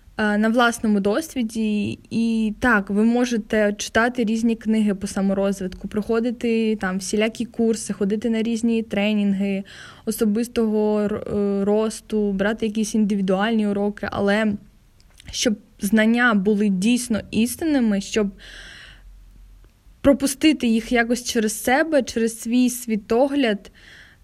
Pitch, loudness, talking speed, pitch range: 220 Hz, -21 LUFS, 100 wpm, 205-235 Hz